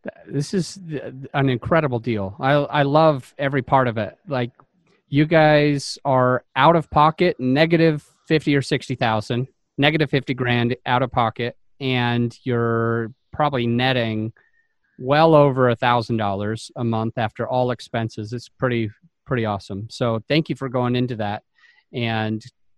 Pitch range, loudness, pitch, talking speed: 115-145 Hz, -20 LUFS, 125 Hz, 155 wpm